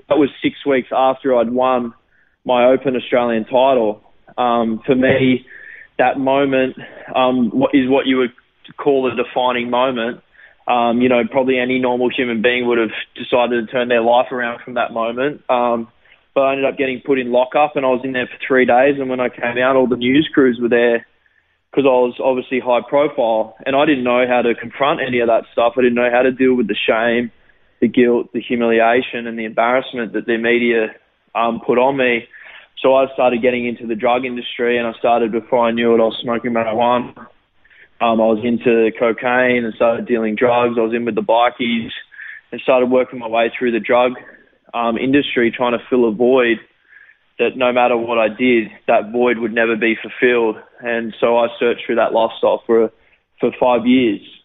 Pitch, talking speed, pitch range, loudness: 120 Hz, 205 wpm, 115-130 Hz, -16 LUFS